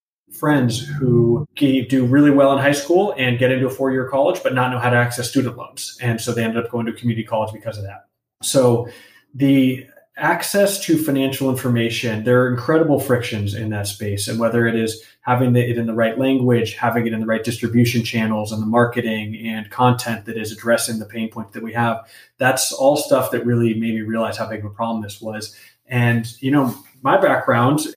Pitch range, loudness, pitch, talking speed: 115-130 Hz, -19 LUFS, 120 Hz, 215 wpm